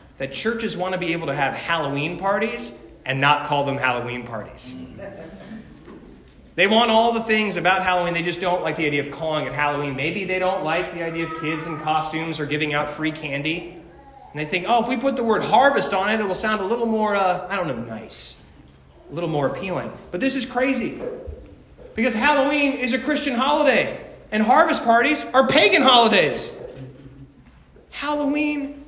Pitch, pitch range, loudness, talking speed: 180 Hz, 150-230 Hz, -21 LUFS, 190 wpm